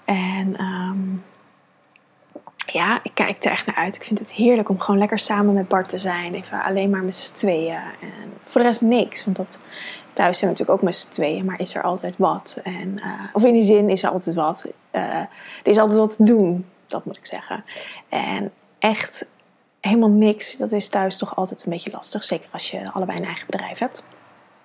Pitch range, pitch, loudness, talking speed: 190-215 Hz, 200 Hz, -21 LUFS, 215 wpm